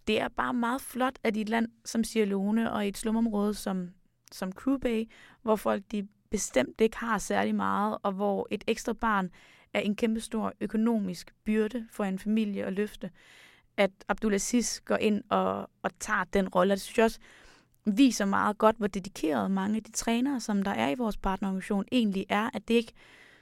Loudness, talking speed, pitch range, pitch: -29 LUFS, 190 wpm, 200-230 Hz, 215 Hz